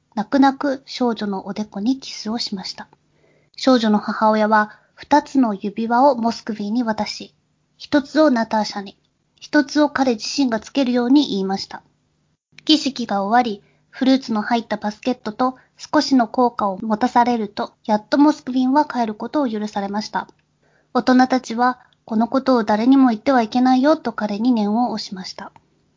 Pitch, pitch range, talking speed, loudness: 240 Hz, 215-265 Hz, 345 characters per minute, -19 LUFS